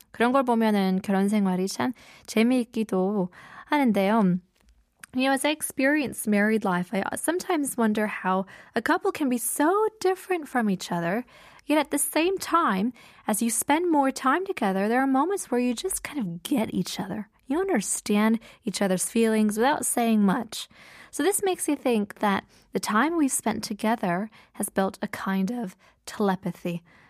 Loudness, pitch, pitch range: -25 LUFS, 225 Hz, 195-285 Hz